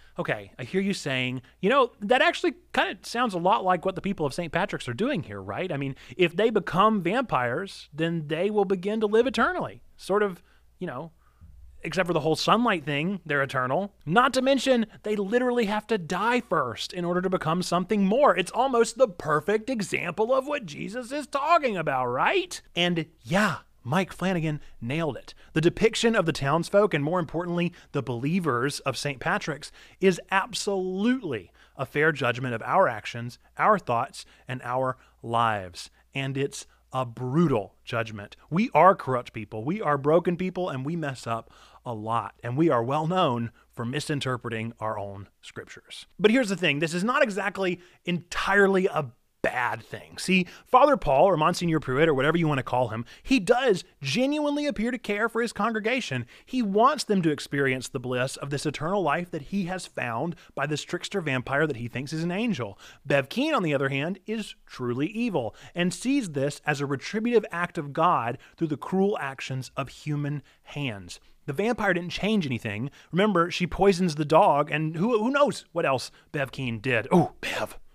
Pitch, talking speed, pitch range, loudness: 170 Hz, 185 wpm, 135-205 Hz, -26 LUFS